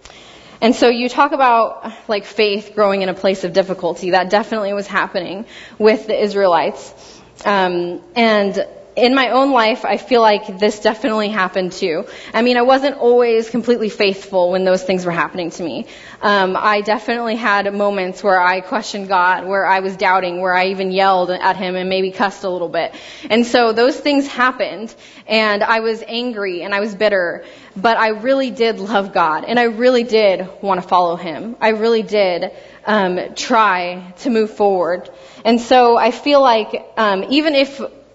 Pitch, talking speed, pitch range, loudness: 210 Hz, 180 wpm, 190-235 Hz, -16 LUFS